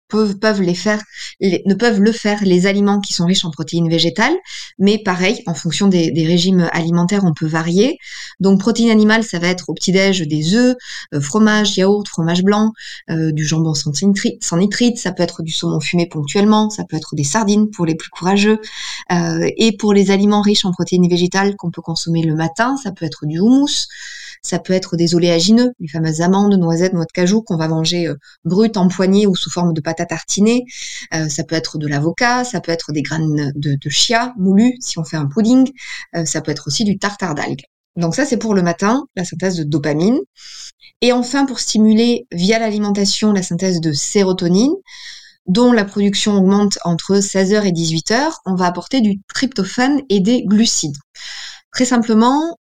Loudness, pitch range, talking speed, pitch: -15 LUFS, 165-215 Hz, 200 wpm, 190 Hz